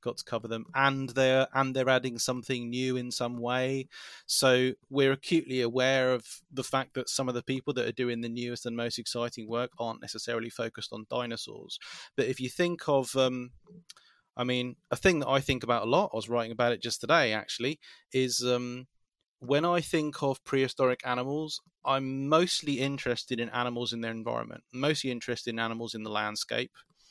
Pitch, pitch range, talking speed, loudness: 125 Hz, 120-135 Hz, 195 wpm, -30 LUFS